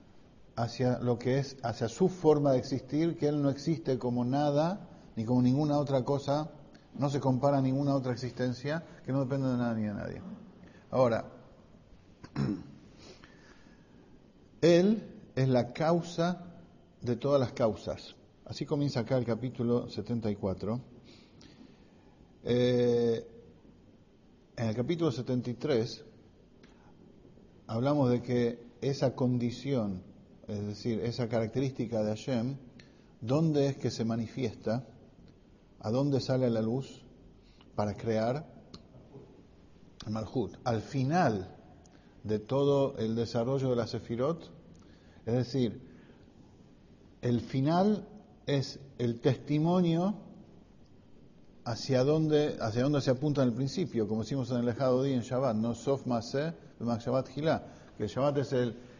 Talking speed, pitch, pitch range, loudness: 125 wpm, 125 Hz, 115-140 Hz, -31 LUFS